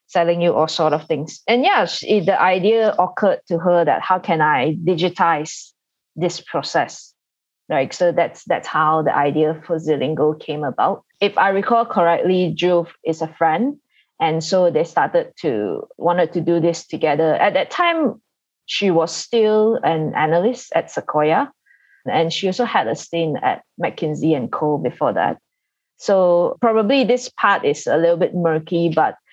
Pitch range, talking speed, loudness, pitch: 160-230 Hz, 170 wpm, -18 LUFS, 175 Hz